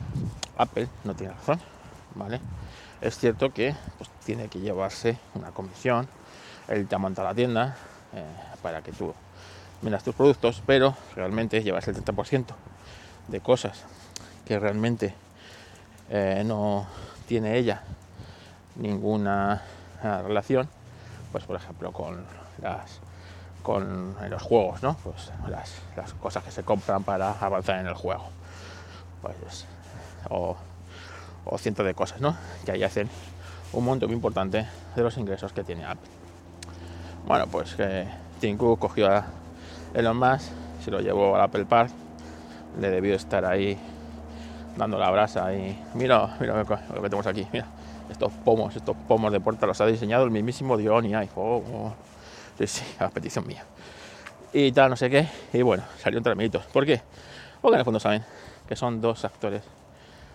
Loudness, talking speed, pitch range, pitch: -27 LUFS, 150 wpm, 90-110 Hz, 100 Hz